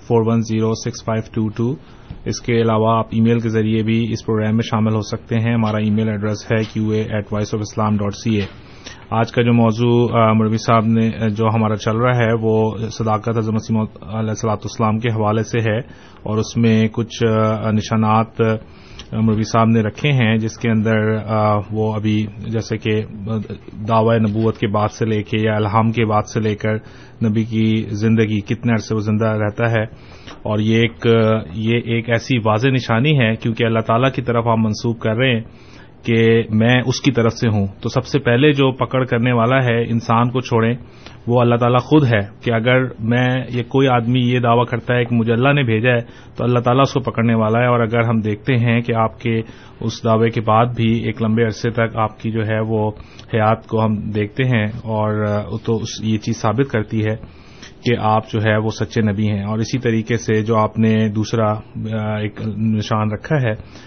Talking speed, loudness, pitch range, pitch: 210 wpm, -18 LUFS, 110-120 Hz, 110 Hz